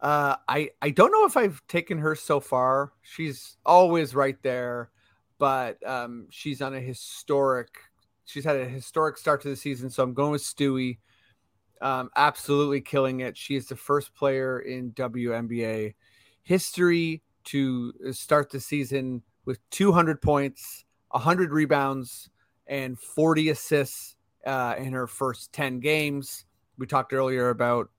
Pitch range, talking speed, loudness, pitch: 125-145 Hz, 145 wpm, -26 LUFS, 135 Hz